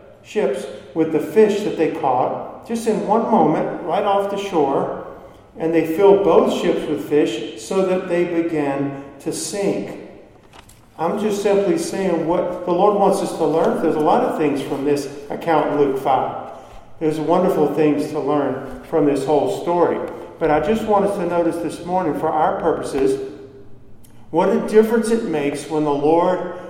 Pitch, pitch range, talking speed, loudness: 160 Hz, 145-190 Hz, 175 wpm, -19 LUFS